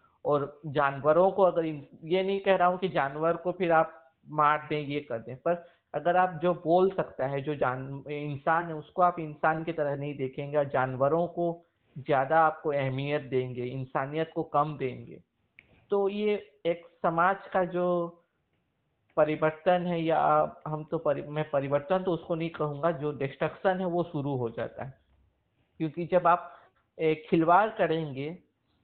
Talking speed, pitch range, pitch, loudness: 165 wpm, 145-175 Hz, 160 Hz, -29 LUFS